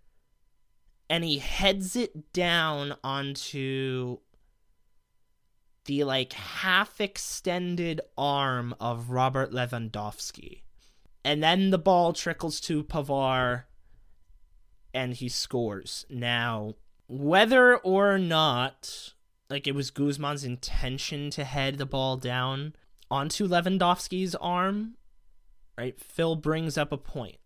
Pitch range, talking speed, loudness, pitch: 125-170 Hz, 105 wpm, -28 LUFS, 140 Hz